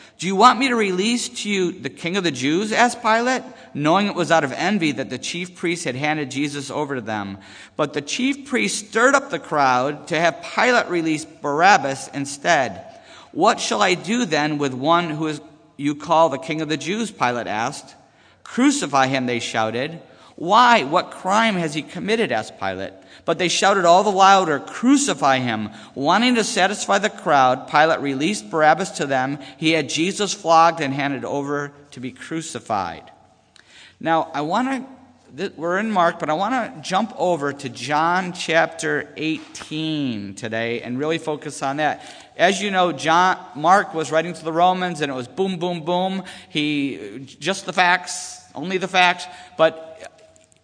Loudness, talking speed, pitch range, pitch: -20 LUFS, 180 wpm, 145-190 Hz, 165 Hz